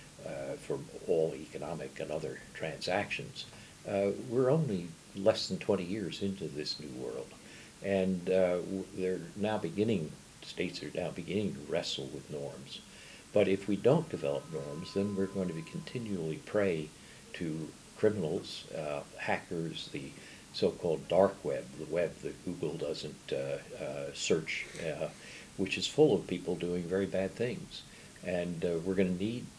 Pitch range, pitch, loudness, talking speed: 90-100 Hz, 95 Hz, -34 LUFS, 150 wpm